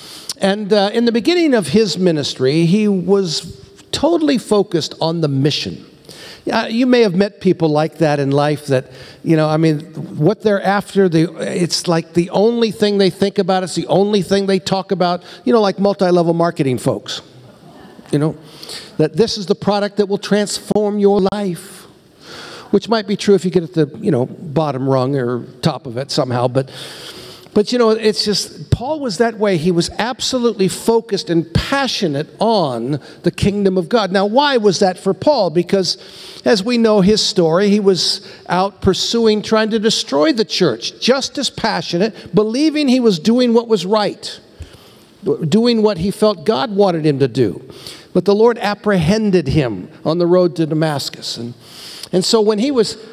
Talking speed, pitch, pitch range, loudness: 185 wpm, 195 Hz, 165-215 Hz, -16 LUFS